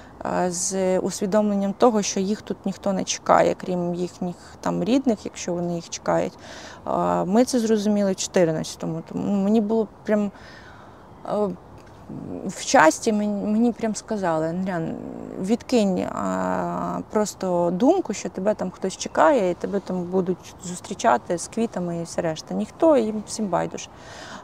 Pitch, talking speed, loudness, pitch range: 195 Hz, 140 wpm, -23 LUFS, 175-215 Hz